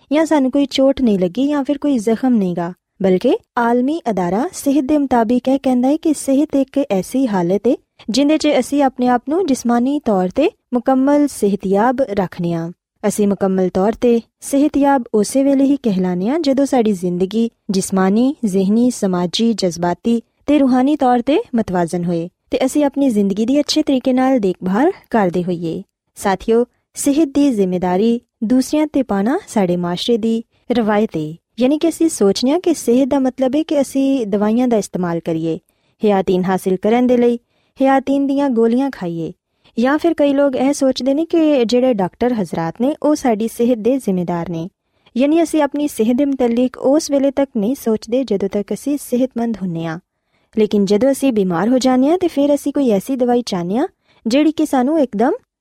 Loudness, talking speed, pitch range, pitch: -16 LUFS, 180 wpm, 200-275 Hz, 245 Hz